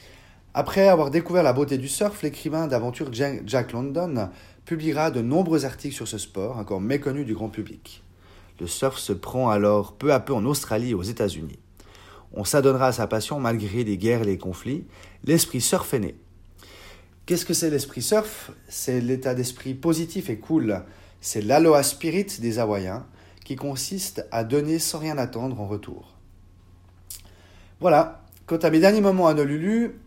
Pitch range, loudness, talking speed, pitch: 100-150 Hz, -24 LUFS, 170 wpm, 125 Hz